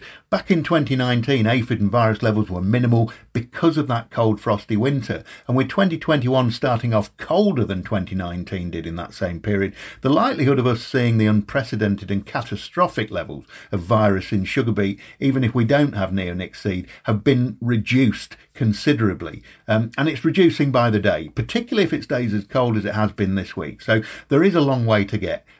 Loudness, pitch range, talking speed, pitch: -21 LUFS, 100-130 Hz, 190 wpm, 115 Hz